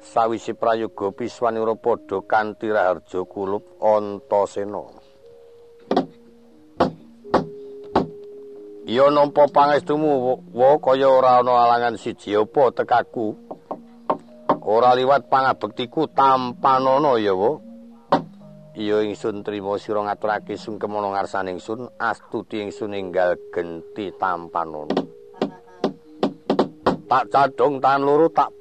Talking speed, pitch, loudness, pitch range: 85 wpm, 125 Hz, -21 LUFS, 105-155 Hz